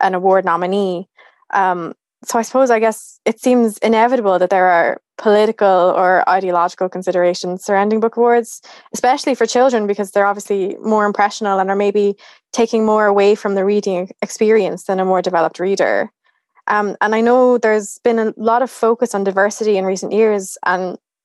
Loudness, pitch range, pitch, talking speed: -15 LUFS, 190-225 Hz, 205 Hz, 170 wpm